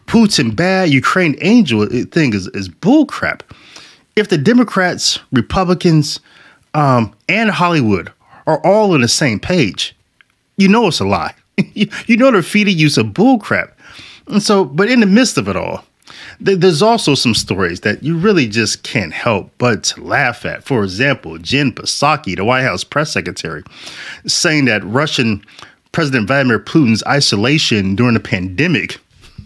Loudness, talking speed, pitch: -13 LUFS, 155 wpm, 150 Hz